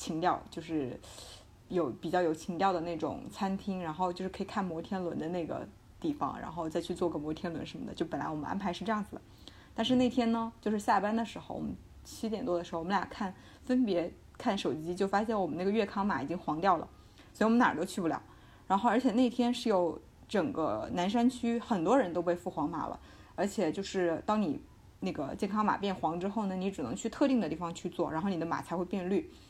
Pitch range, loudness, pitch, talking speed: 175-225 Hz, -33 LUFS, 195 Hz, 340 characters per minute